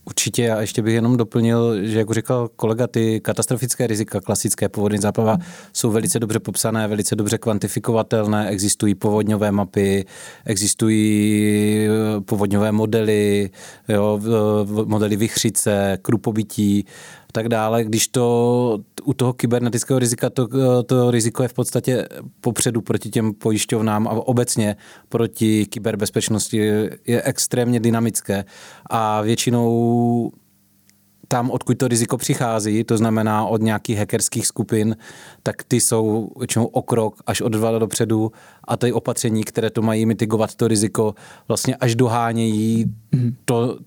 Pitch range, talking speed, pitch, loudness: 105-120 Hz, 130 wpm, 115 Hz, -19 LUFS